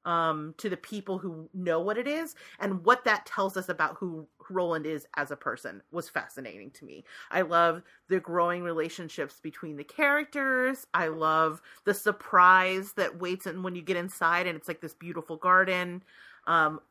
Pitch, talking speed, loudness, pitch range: 180 Hz, 180 wpm, -28 LUFS, 160-195 Hz